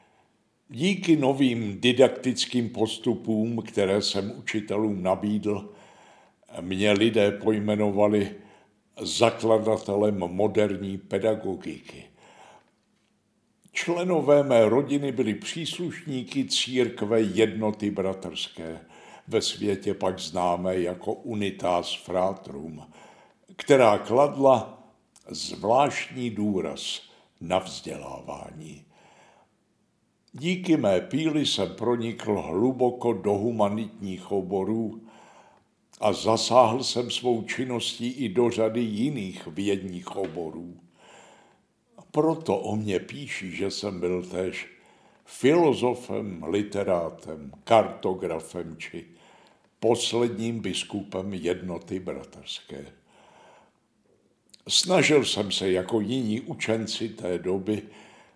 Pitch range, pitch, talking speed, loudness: 95-120 Hz, 105 Hz, 80 wpm, -26 LUFS